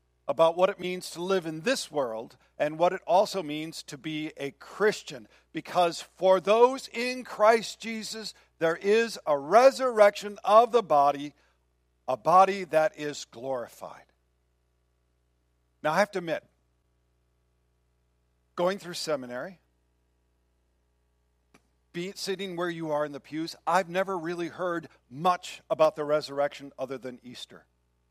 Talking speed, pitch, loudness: 135 wpm, 155 Hz, -27 LUFS